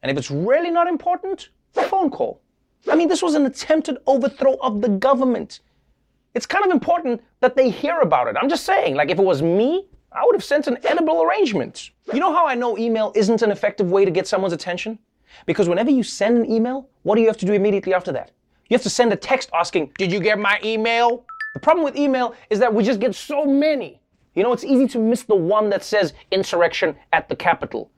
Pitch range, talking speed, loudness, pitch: 205-290 Hz, 235 wpm, -19 LUFS, 245 Hz